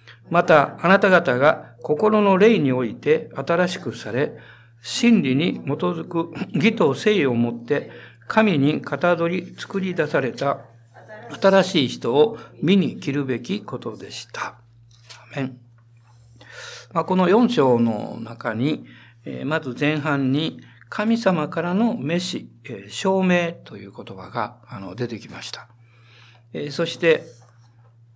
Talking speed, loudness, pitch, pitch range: 210 characters per minute, -21 LUFS, 145 Hz, 120-180 Hz